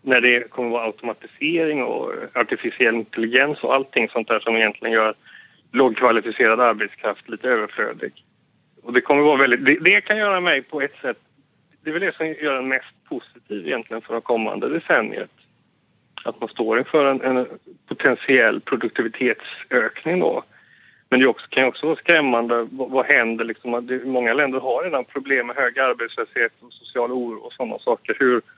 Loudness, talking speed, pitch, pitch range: -20 LUFS, 175 wpm, 130 Hz, 120-150 Hz